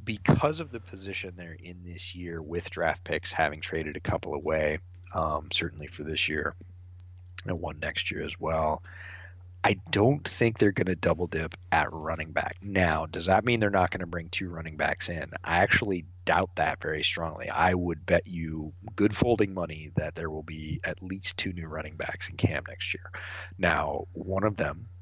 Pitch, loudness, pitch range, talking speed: 90 Hz, -29 LUFS, 80-95 Hz, 195 wpm